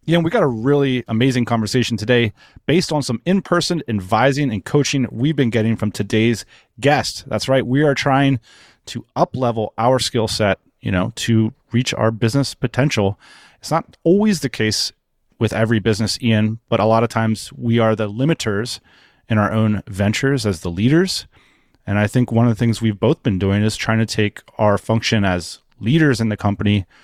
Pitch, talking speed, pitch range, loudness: 115 Hz, 190 wpm, 110-135 Hz, -18 LUFS